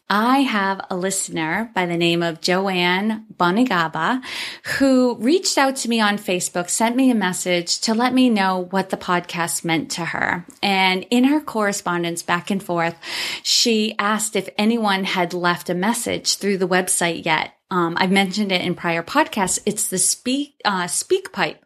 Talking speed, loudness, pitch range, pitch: 175 wpm, -19 LUFS, 175-225 Hz, 190 Hz